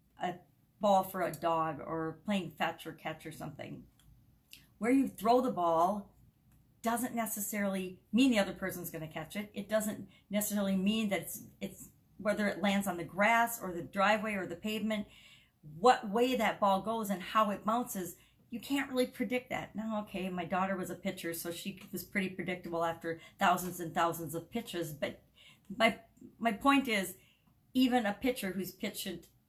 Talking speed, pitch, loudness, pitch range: 175 wpm, 195 Hz, -34 LUFS, 175-220 Hz